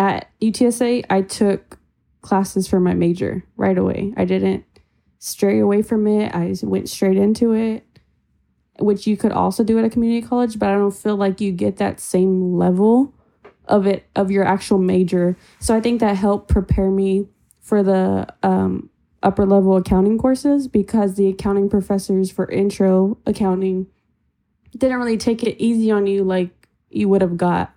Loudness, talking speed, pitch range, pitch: -18 LUFS, 175 wpm, 185-215 Hz, 195 Hz